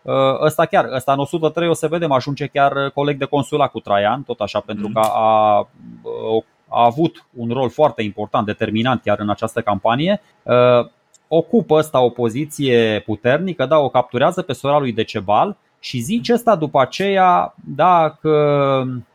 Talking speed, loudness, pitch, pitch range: 155 wpm, -17 LUFS, 135 Hz, 115-155 Hz